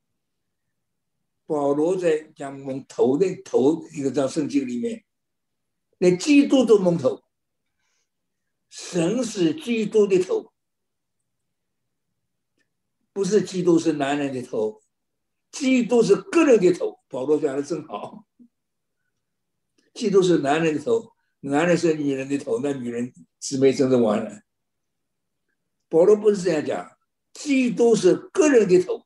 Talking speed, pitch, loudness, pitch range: 180 characters per minute, 185 Hz, -21 LUFS, 150-245 Hz